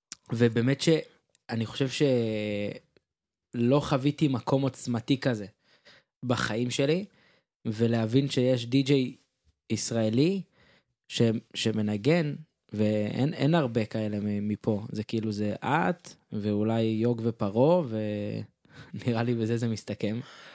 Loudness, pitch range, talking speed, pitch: -28 LUFS, 110-135 Hz, 90 wpm, 115 Hz